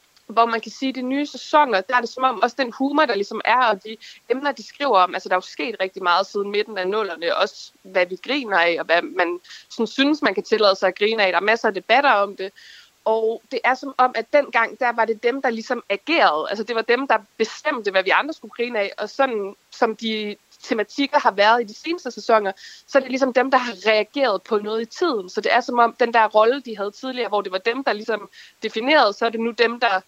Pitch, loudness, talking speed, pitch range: 225 Hz, -20 LUFS, 265 wpm, 205-255 Hz